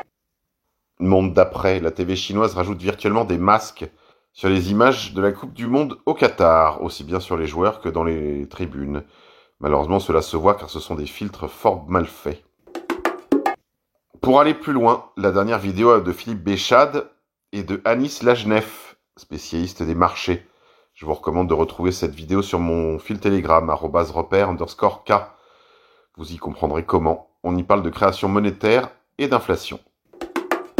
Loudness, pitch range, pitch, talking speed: -20 LUFS, 85-110 Hz, 95 Hz, 160 wpm